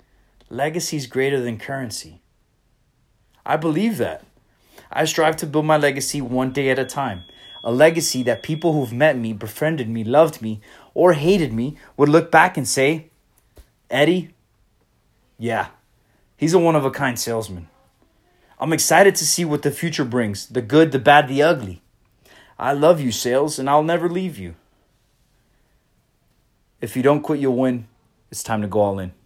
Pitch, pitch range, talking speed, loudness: 135 Hz, 115-155 Hz, 170 wpm, -19 LUFS